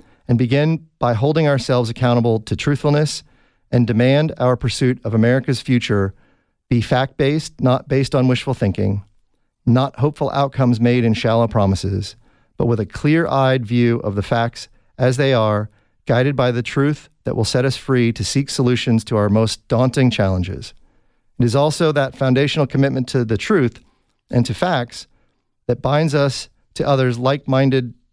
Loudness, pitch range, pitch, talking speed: -18 LUFS, 115-135 Hz, 125 Hz, 165 wpm